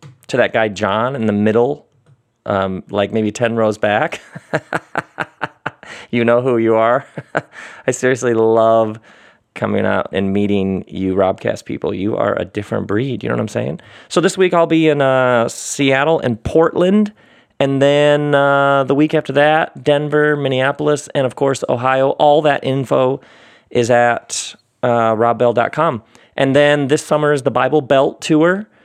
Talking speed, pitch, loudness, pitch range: 160 wpm, 130 Hz, -16 LUFS, 115-145 Hz